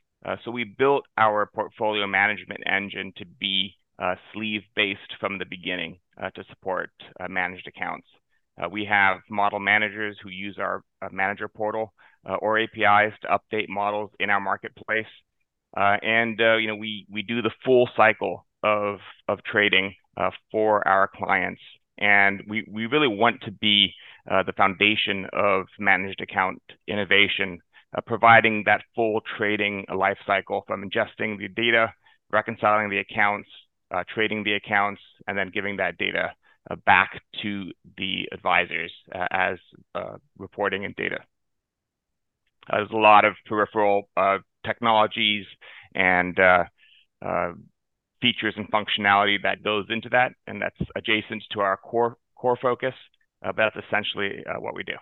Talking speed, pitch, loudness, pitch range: 155 wpm, 105 Hz, -23 LUFS, 100-110 Hz